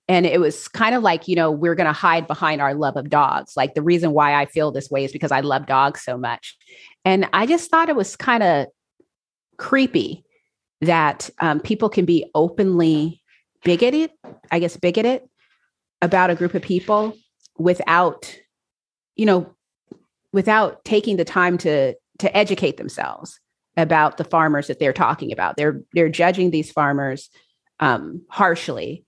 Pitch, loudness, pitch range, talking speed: 175 Hz, -19 LUFS, 150-200 Hz, 165 wpm